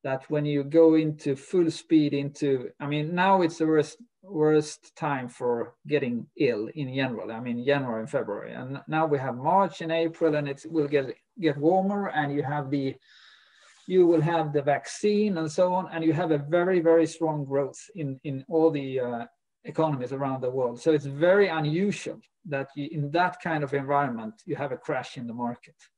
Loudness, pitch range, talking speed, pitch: -26 LUFS, 140-165 Hz, 200 wpm, 150 Hz